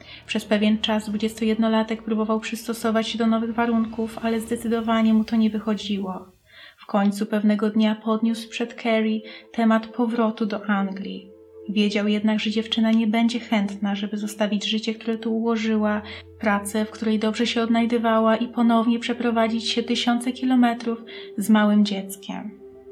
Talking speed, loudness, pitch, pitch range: 145 wpm, -23 LUFS, 220 Hz, 215-230 Hz